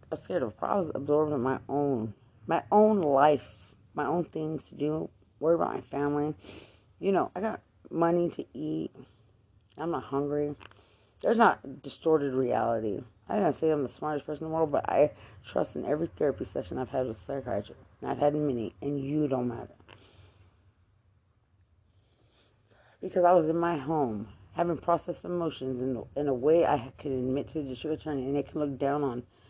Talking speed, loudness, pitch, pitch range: 185 wpm, -30 LUFS, 135 Hz, 105-150 Hz